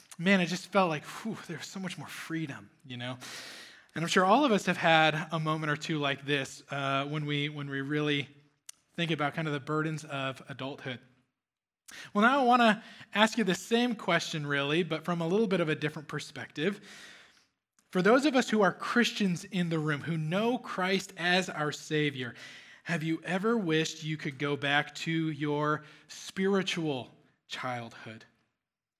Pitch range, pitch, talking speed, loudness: 145-185 Hz, 160 Hz, 180 wpm, -30 LUFS